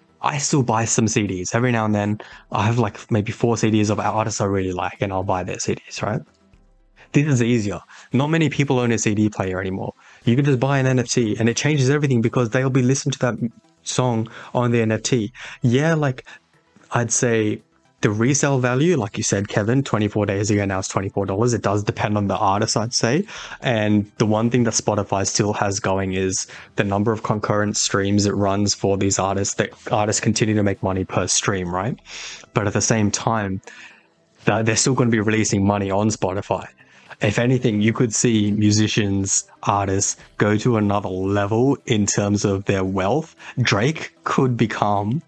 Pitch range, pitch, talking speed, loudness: 100-125 Hz, 110 Hz, 190 wpm, -20 LUFS